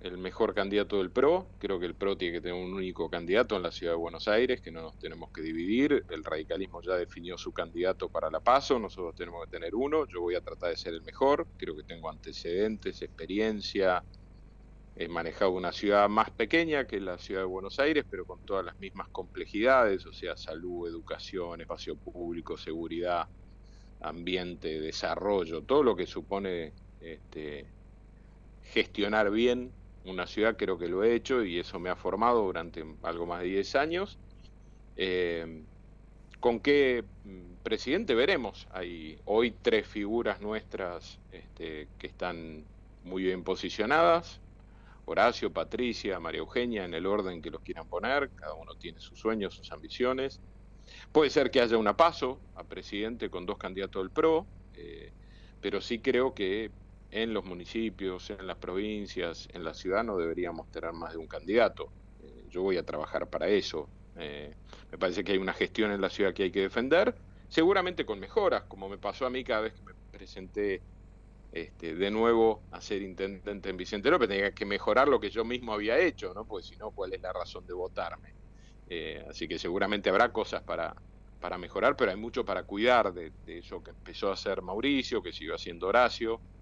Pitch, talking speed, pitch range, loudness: 95 Hz, 180 wpm, 90-110 Hz, -31 LUFS